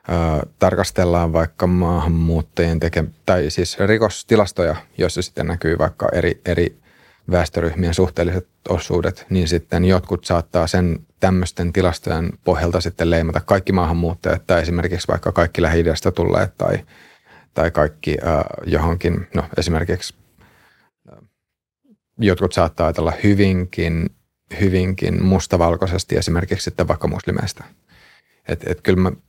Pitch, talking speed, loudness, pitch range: 85 Hz, 120 wpm, -19 LUFS, 85-95 Hz